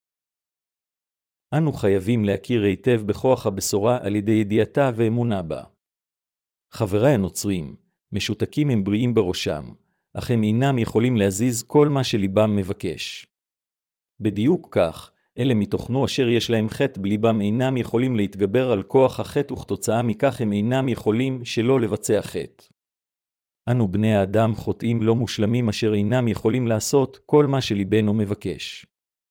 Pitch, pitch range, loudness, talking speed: 110 Hz, 105-125 Hz, -22 LUFS, 130 wpm